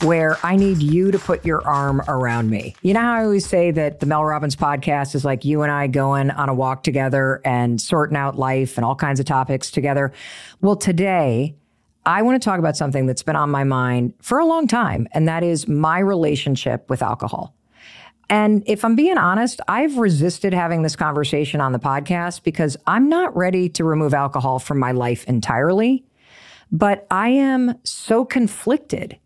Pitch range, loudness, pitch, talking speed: 135-195 Hz, -19 LUFS, 155 Hz, 195 wpm